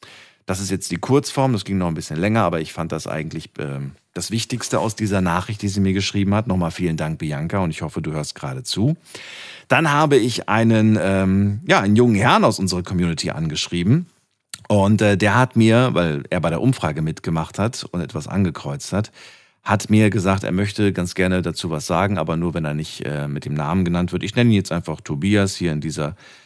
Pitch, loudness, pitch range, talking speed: 95 Hz, -20 LUFS, 85-110 Hz, 220 wpm